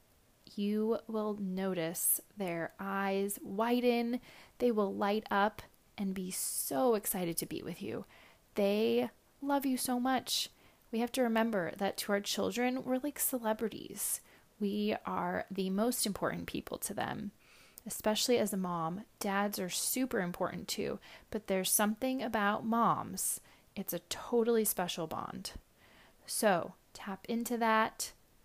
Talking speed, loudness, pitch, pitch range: 135 wpm, -34 LUFS, 210 Hz, 195-235 Hz